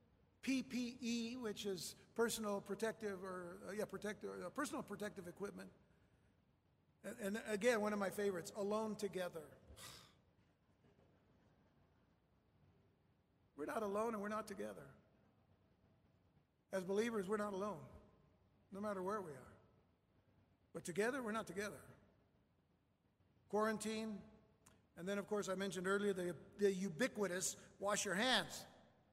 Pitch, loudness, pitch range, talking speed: 200 Hz, -43 LUFS, 130-210 Hz, 120 wpm